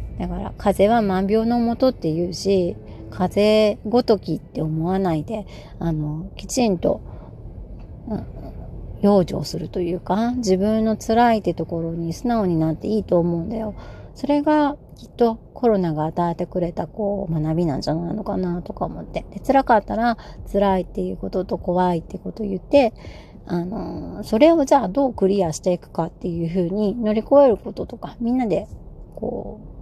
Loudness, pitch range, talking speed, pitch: -21 LUFS, 175-225 Hz, 340 characters per minute, 195 Hz